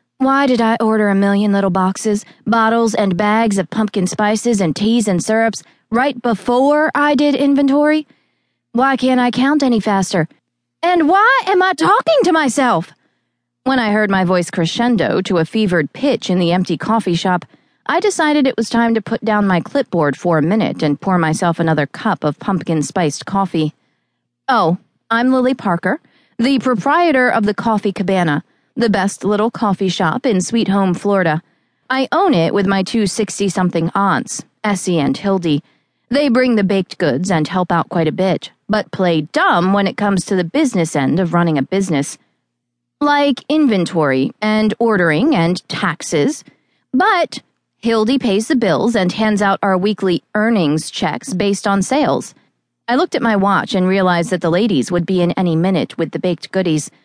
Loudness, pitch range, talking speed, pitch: -15 LUFS, 175-235 Hz, 180 wpm, 200 Hz